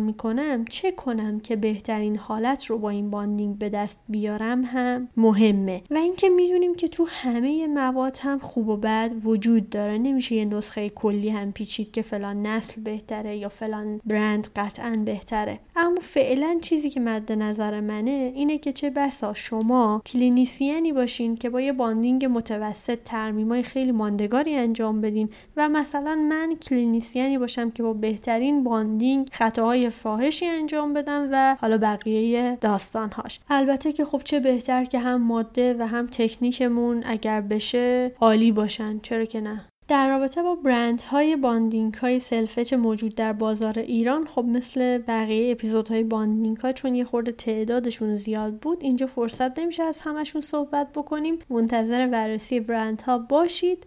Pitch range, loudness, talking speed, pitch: 220-270 Hz, -24 LUFS, 155 wpm, 235 Hz